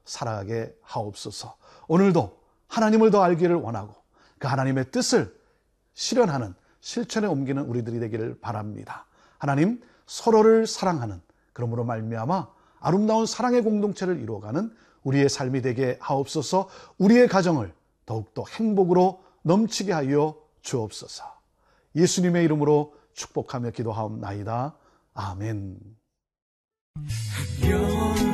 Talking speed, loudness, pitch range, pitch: 290 characters per minute, -24 LUFS, 115-190 Hz, 145 Hz